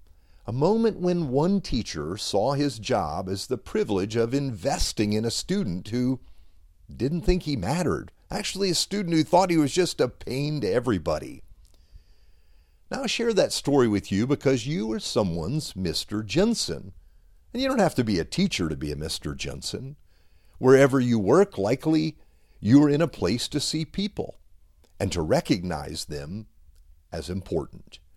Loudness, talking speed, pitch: -25 LUFS, 165 wpm, 120 Hz